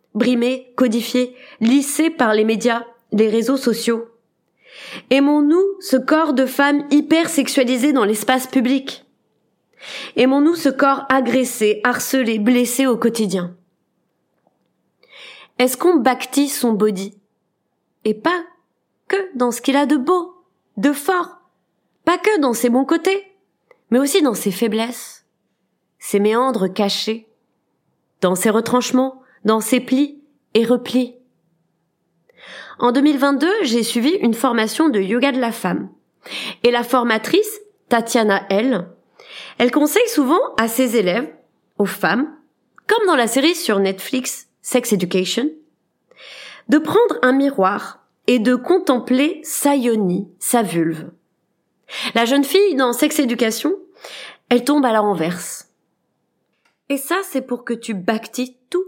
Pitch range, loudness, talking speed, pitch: 220-285 Hz, -18 LUFS, 130 wpm, 250 Hz